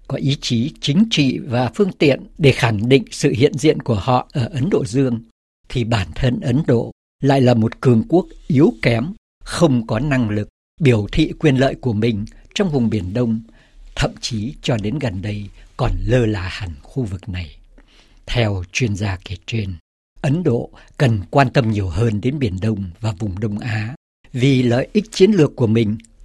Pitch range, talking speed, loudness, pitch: 105-135 Hz, 195 wpm, -18 LUFS, 120 Hz